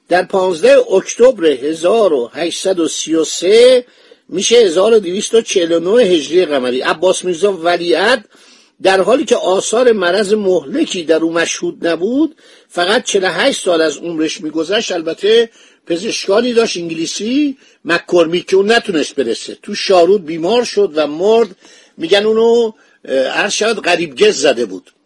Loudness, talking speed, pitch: -13 LUFS, 115 wpm, 205 Hz